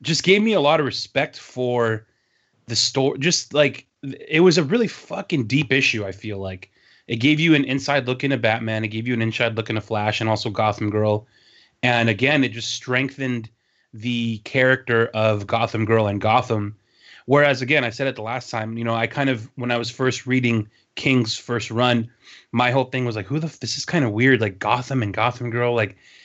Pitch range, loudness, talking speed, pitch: 110-135 Hz, -21 LUFS, 220 wpm, 120 Hz